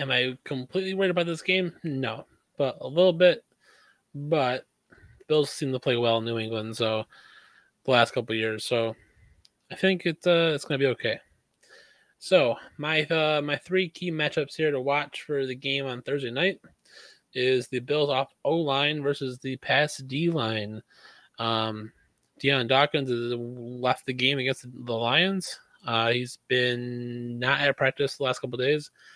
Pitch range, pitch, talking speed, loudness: 120-155 Hz, 135 Hz, 175 wpm, -26 LUFS